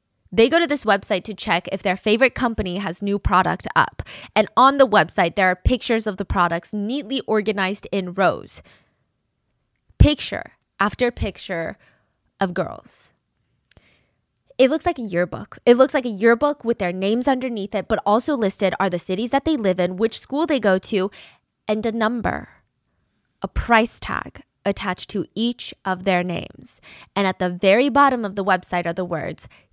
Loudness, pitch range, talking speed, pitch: -20 LUFS, 190-240 Hz, 175 wpm, 210 Hz